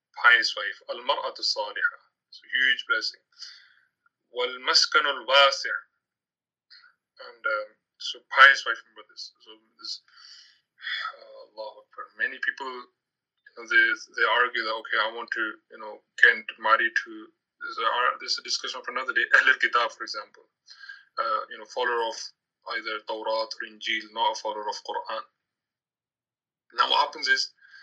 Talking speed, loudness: 145 wpm, -24 LUFS